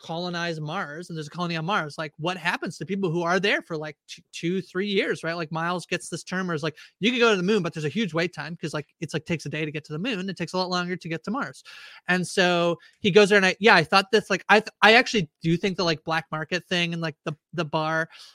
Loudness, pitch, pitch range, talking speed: -24 LUFS, 175 Hz, 160-195 Hz, 300 wpm